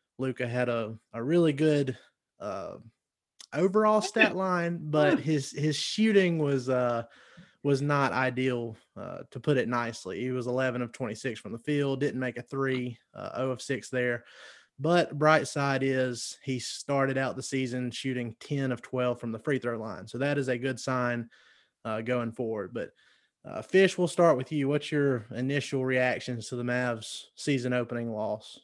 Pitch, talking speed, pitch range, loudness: 130 Hz, 180 wpm, 120-145 Hz, -29 LUFS